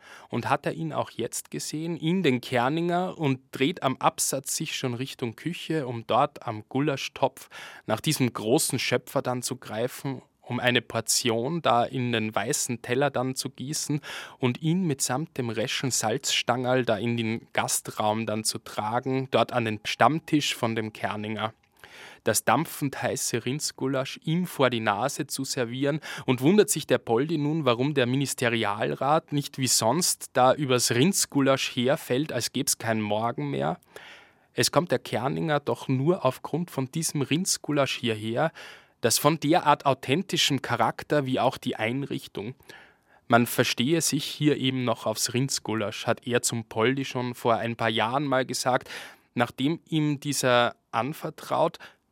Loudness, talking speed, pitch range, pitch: -26 LUFS, 155 wpm, 120-145 Hz, 130 Hz